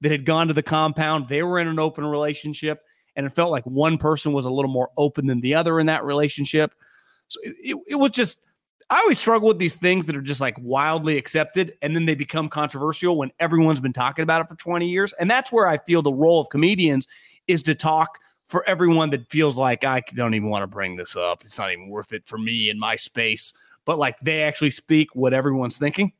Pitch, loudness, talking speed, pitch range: 155 Hz, -21 LUFS, 235 wpm, 135-165 Hz